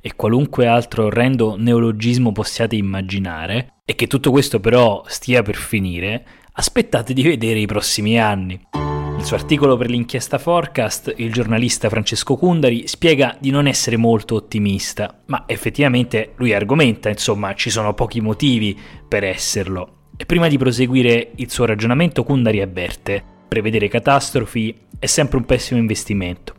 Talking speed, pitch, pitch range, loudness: 145 wpm, 115 Hz, 105-130 Hz, -17 LUFS